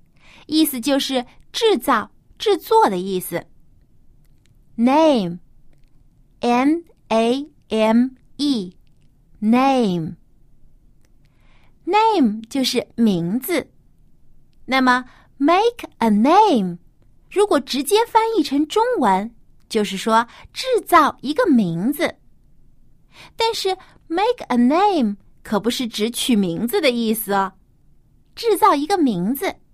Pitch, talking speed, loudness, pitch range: 255 Hz, 180 characters per minute, -19 LUFS, 215-330 Hz